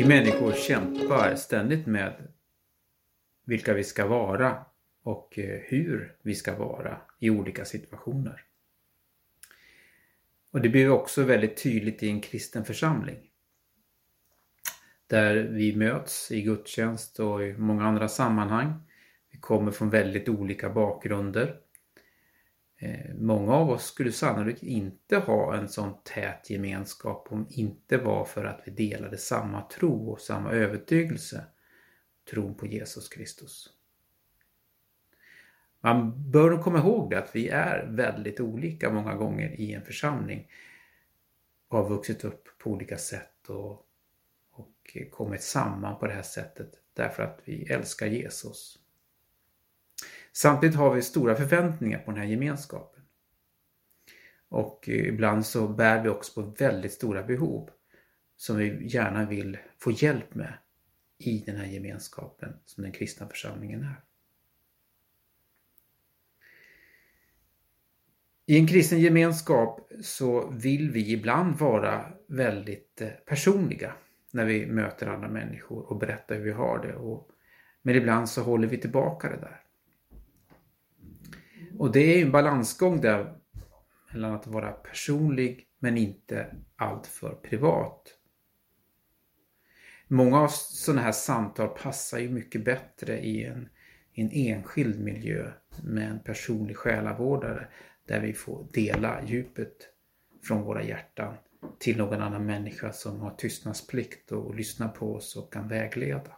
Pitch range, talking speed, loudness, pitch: 105-135 Hz, 125 wpm, -28 LUFS, 110 Hz